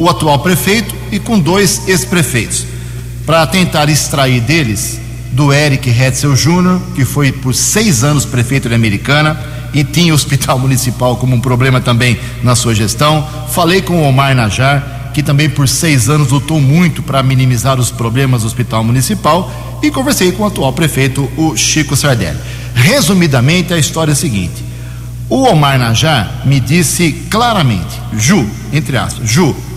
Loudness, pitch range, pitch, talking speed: -11 LUFS, 125-155 Hz, 135 Hz, 160 wpm